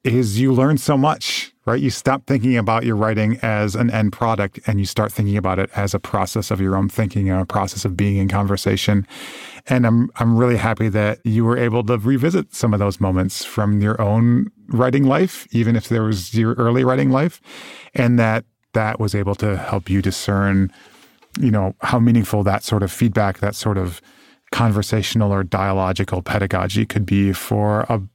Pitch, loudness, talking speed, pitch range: 110 Hz, -19 LUFS, 195 wpm, 100-120 Hz